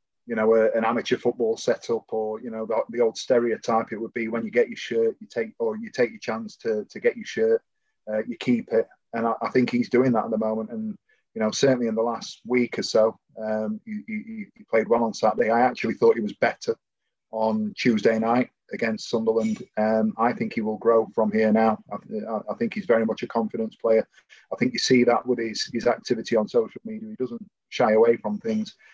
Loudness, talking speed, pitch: -24 LUFS, 230 wpm, 120 Hz